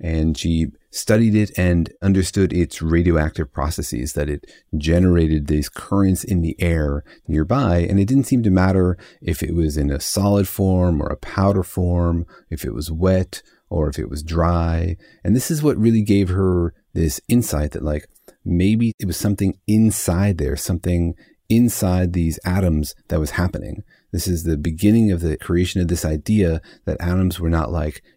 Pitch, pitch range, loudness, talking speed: 85 Hz, 80-95 Hz, -20 LUFS, 175 wpm